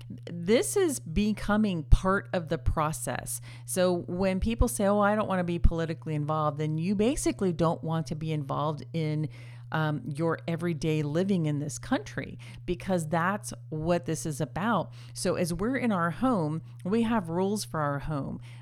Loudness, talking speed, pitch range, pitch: -29 LUFS, 170 wpm, 150-190 Hz, 165 Hz